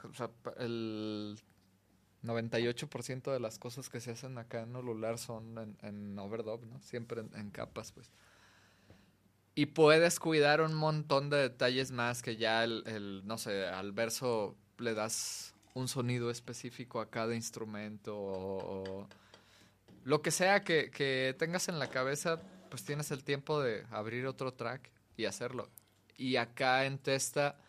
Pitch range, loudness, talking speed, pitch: 110-135 Hz, -35 LUFS, 155 wpm, 120 Hz